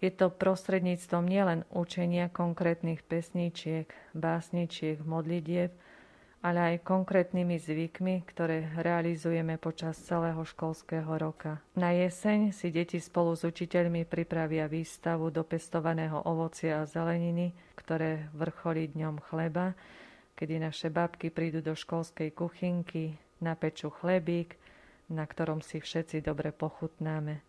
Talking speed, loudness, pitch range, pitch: 115 wpm, -33 LUFS, 160-175 Hz, 165 Hz